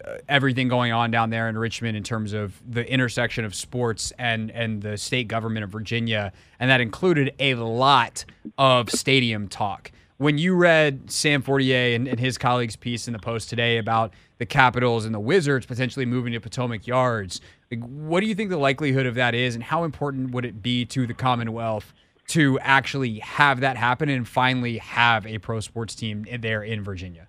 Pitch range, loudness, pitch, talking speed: 115-135 Hz, -23 LUFS, 120 Hz, 195 wpm